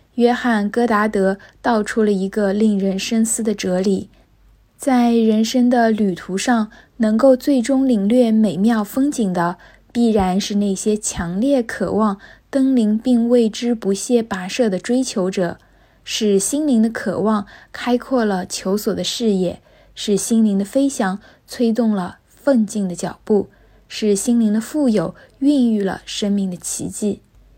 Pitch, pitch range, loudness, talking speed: 220 Hz, 195-240 Hz, -18 LUFS, 215 characters per minute